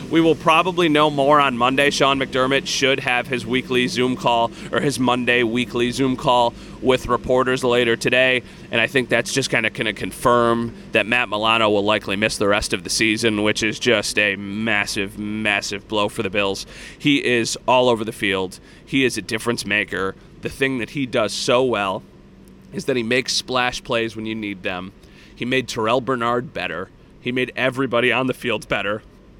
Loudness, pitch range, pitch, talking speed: -19 LUFS, 110-130 Hz, 120 Hz, 195 wpm